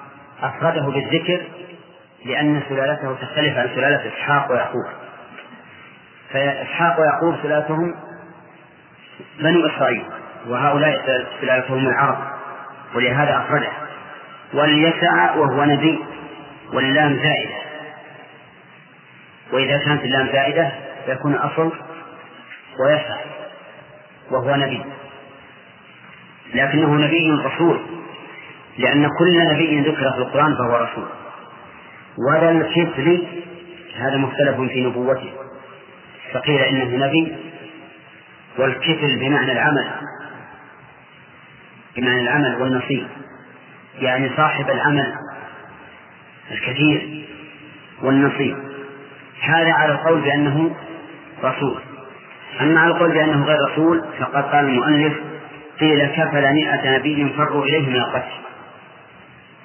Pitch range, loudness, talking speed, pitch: 135-155 Hz, -18 LUFS, 85 wpm, 145 Hz